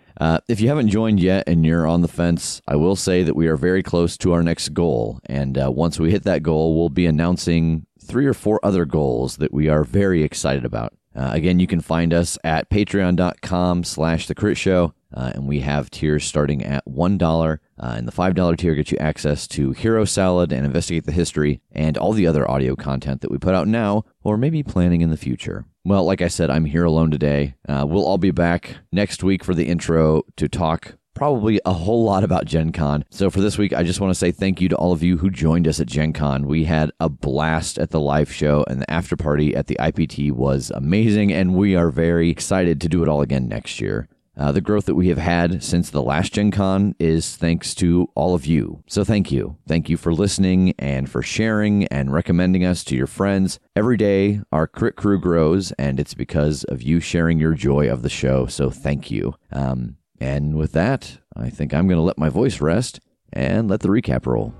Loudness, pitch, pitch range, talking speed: -20 LUFS, 85 Hz, 75-95 Hz, 225 wpm